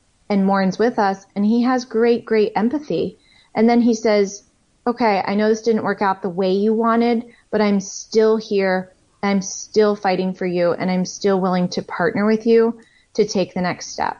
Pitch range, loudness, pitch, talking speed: 195-230 Hz, -19 LUFS, 205 Hz, 200 wpm